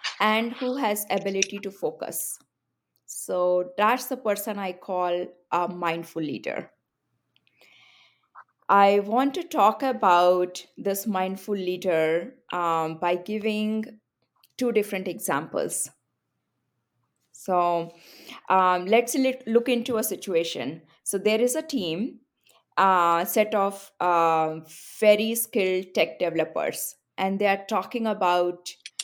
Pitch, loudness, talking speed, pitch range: 195 Hz, -25 LUFS, 115 wpm, 175-220 Hz